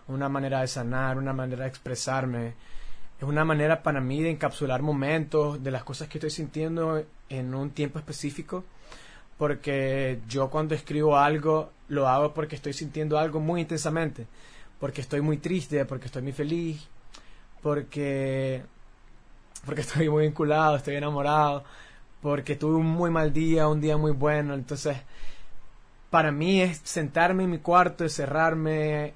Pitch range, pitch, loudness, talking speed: 135-155 Hz, 150 Hz, -27 LUFS, 150 wpm